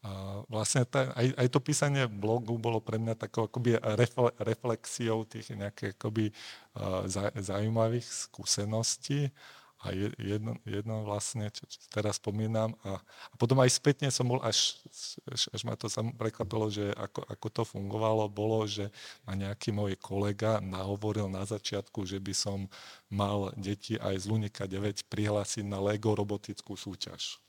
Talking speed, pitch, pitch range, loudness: 150 wpm, 110 Hz, 100-115 Hz, -33 LUFS